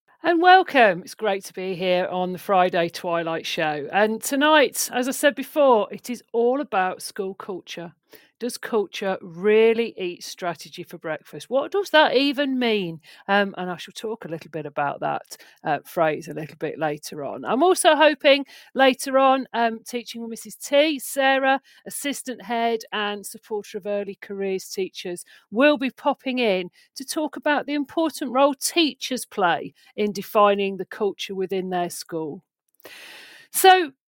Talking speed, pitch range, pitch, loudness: 160 wpm, 185-275 Hz, 225 Hz, -22 LUFS